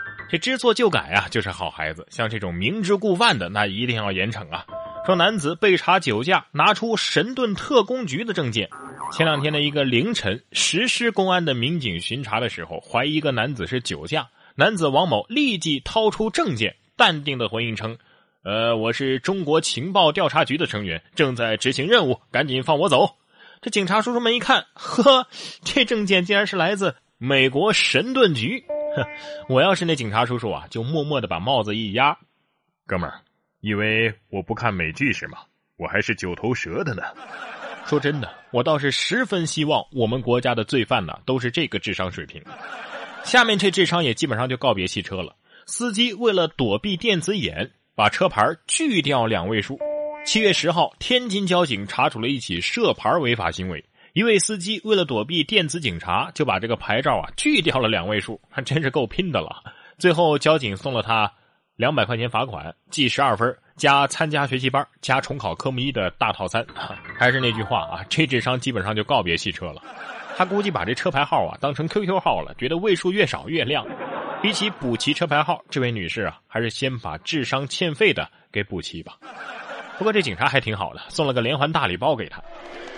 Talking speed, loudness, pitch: 290 characters per minute, -21 LUFS, 140 Hz